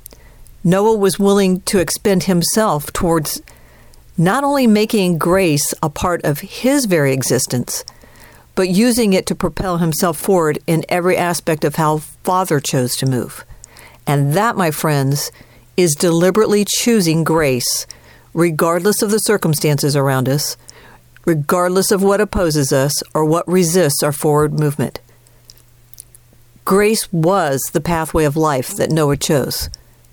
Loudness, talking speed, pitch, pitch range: -16 LUFS, 135 wpm, 165 Hz, 140-190 Hz